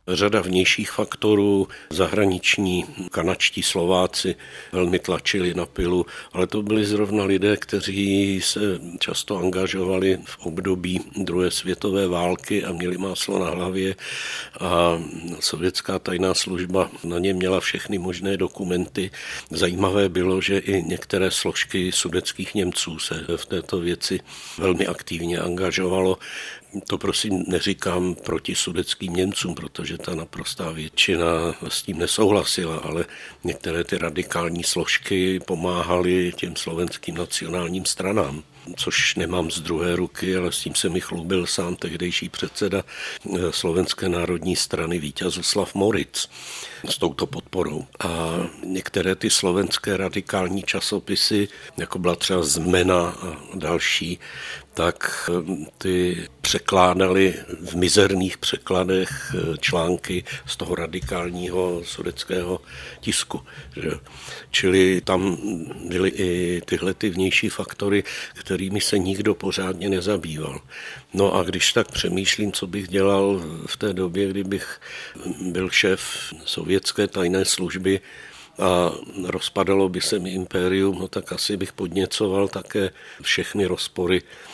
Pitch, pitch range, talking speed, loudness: 95 Hz, 90-95 Hz, 120 wpm, -23 LUFS